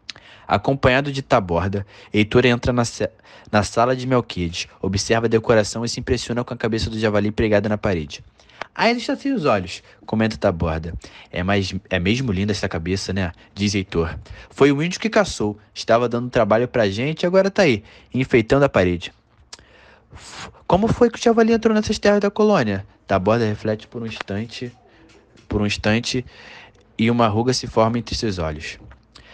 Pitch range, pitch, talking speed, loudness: 100-130 Hz, 110 Hz, 175 wpm, -20 LUFS